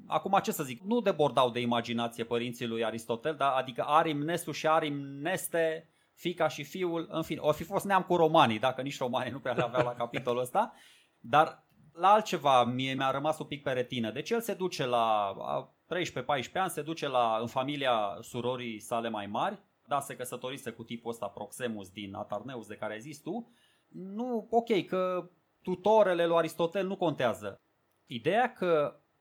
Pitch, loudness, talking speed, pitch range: 145 Hz, -31 LUFS, 180 wpm, 120-170 Hz